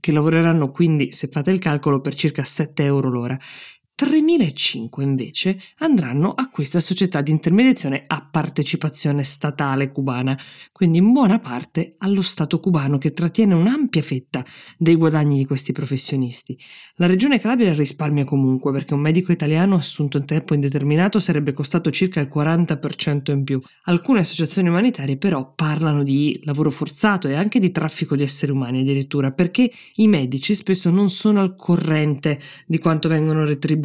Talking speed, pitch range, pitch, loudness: 155 wpm, 145-180 Hz, 155 Hz, -19 LUFS